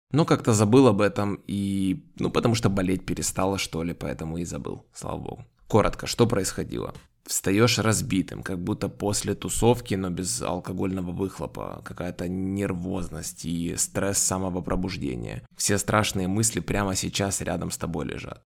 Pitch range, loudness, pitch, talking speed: 90-105 Hz, -26 LUFS, 95 Hz, 150 wpm